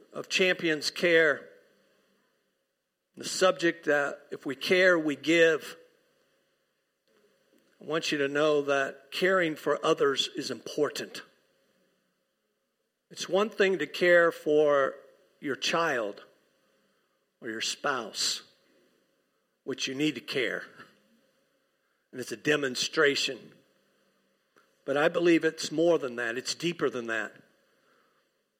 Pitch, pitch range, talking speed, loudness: 165 Hz, 150-185 Hz, 110 wpm, -27 LUFS